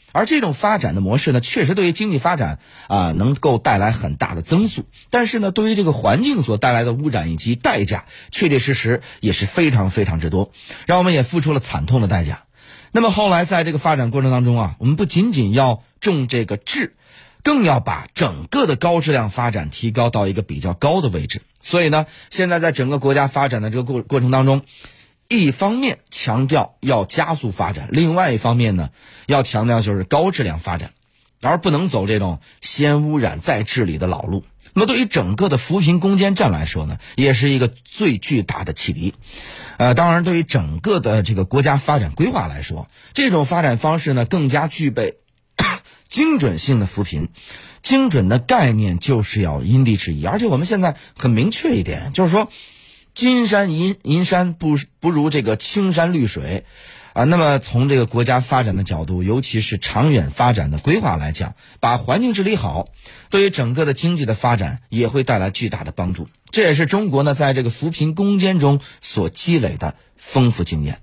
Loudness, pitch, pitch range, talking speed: -18 LUFS, 130 Hz, 110-165 Hz, 295 characters per minute